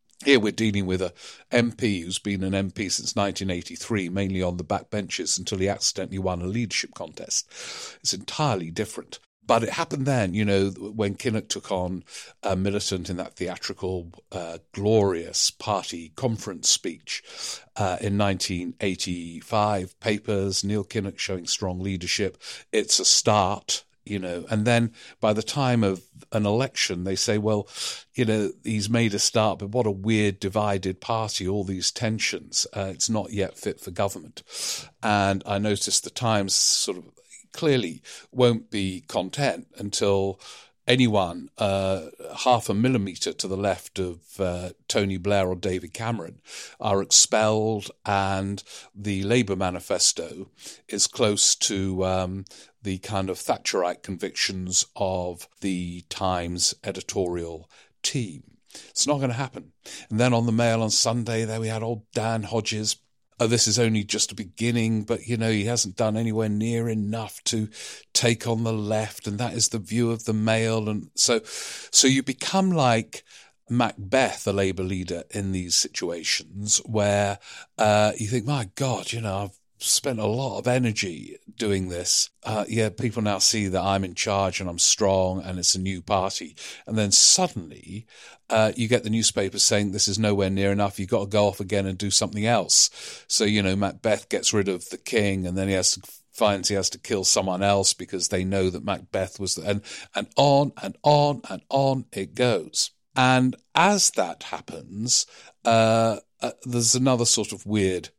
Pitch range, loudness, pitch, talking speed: 95-115 Hz, -24 LUFS, 105 Hz, 170 wpm